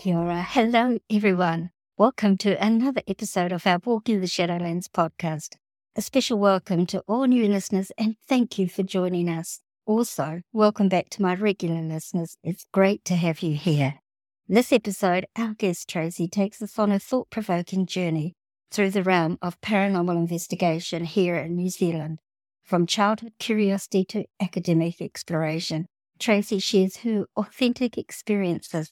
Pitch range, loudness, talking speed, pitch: 170-210 Hz, -24 LUFS, 145 wpm, 190 Hz